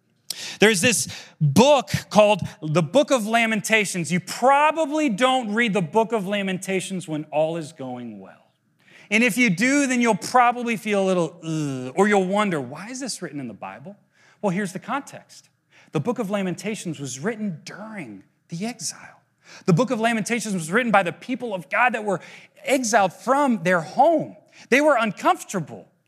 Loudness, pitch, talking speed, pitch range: -21 LUFS, 205 Hz, 175 wpm, 170-240 Hz